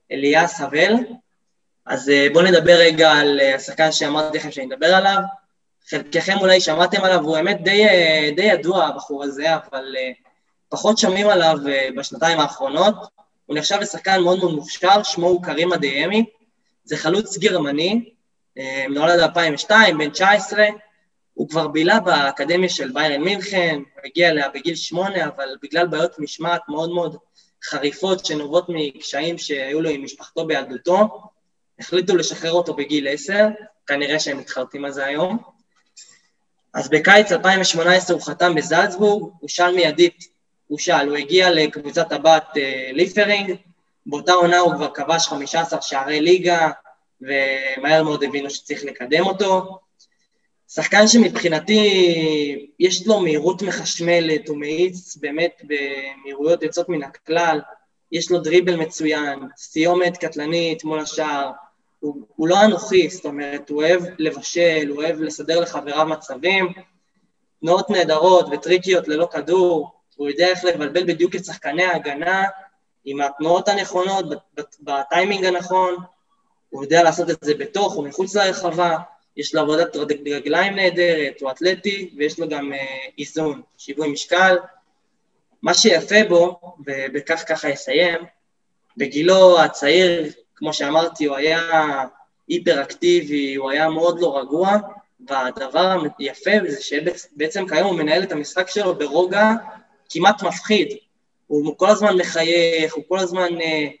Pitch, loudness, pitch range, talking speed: 165 Hz, -18 LUFS, 150-185 Hz, 130 wpm